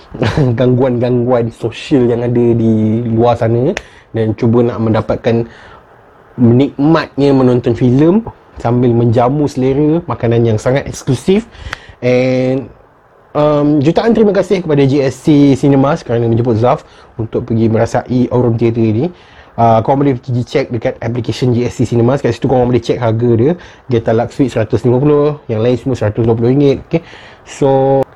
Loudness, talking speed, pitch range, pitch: -12 LUFS, 135 wpm, 115-140 Hz, 125 Hz